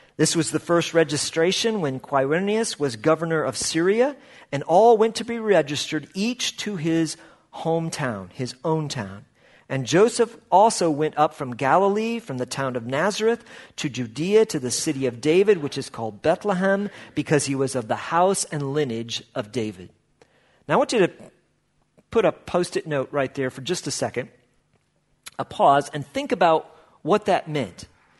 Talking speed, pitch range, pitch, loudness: 170 wpm, 135-190 Hz, 155 Hz, -23 LUFS